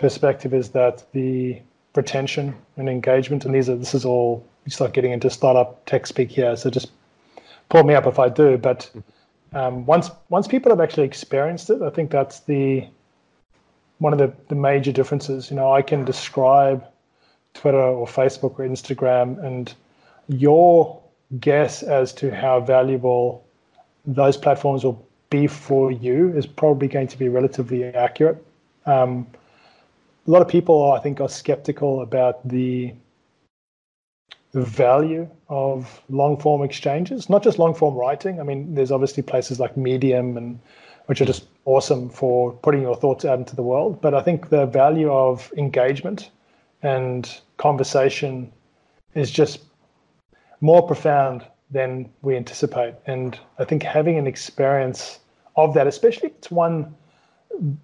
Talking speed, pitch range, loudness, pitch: 150 wpm, 130-150 Hz, -20 LUFS, 135 Hz